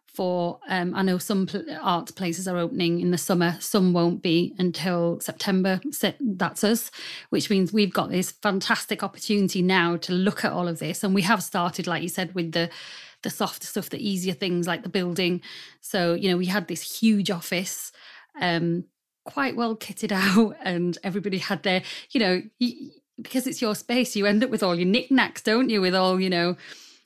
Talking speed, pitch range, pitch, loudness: 195 wpm, 175-210 Hz, 190 Hz, -25 LUFS